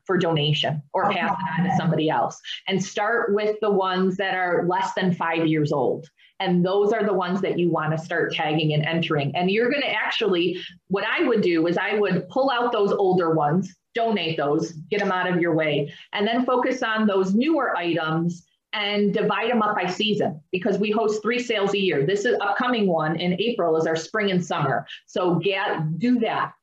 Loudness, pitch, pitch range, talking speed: -23 LUFS, 185 Hz, 165-210 Hz, 210 wpm